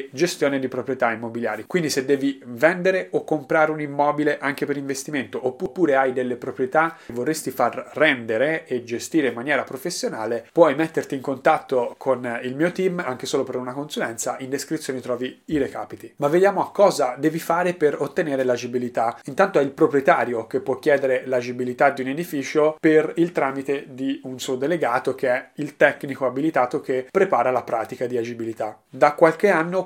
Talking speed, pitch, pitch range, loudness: 175 wpm, 140 Hz, 125-160 Hz, -22 LUFS